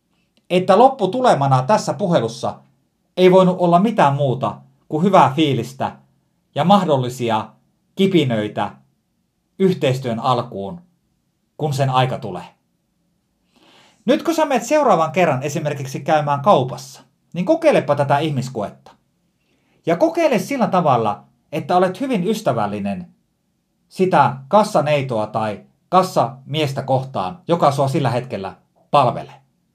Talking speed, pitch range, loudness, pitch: 110 wpm, 130-190 Hz, -18 LUFS, 155 Hz